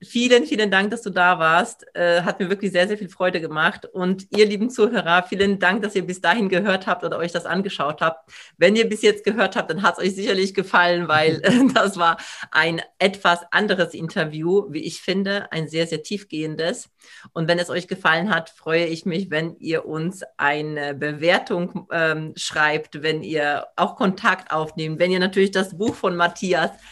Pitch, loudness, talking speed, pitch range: 175 Hz, -21 LUFS, 195 wpm, 160-195 Hz